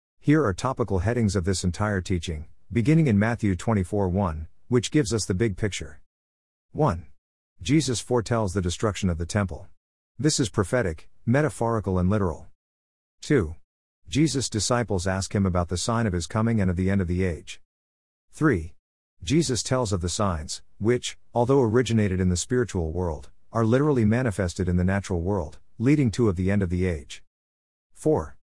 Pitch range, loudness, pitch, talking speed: 85-115 Hz, -25 LUFS, 100 Hz, 170 wpm